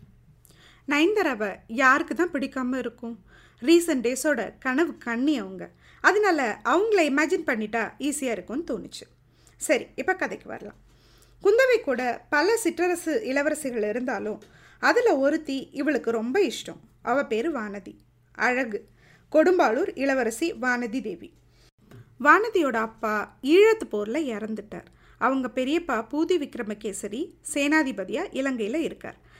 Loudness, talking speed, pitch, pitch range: -25 LUFS, 105 wpm, 270 Hz, 230-325 Hz